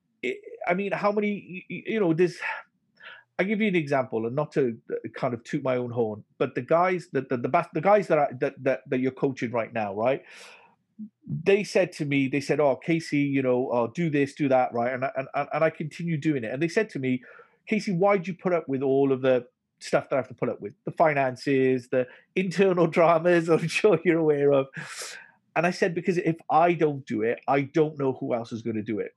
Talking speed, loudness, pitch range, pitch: 235 wpm, -26 LUFS, 135-180 Hz, 155 Hz